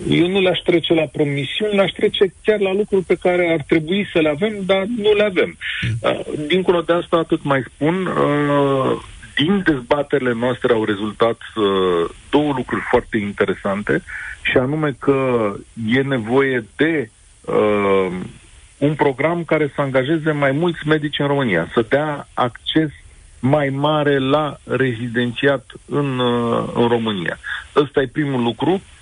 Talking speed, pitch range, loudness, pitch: 135 wpm, 125-165 Hz, -18 LUFS, 145 Hz